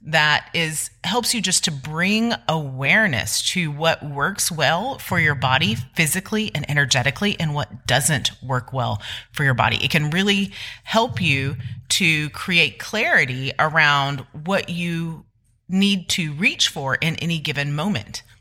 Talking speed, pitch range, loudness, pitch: 145 wpm, 135-180 Hz, -20 LUFS, 155 Hz